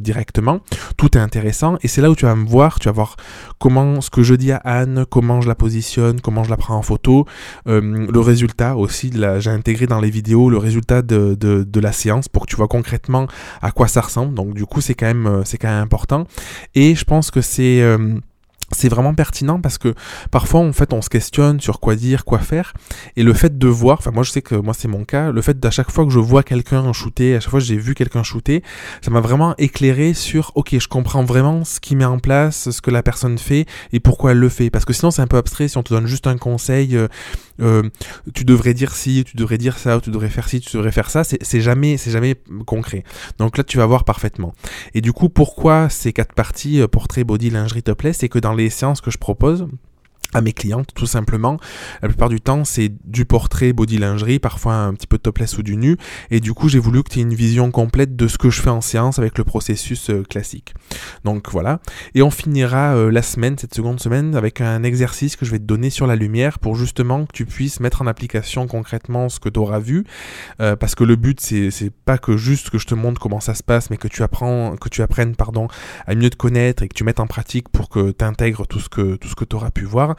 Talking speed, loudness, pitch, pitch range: 255 wpm, -17 LUFS, 120 Hz, 110-130 Hz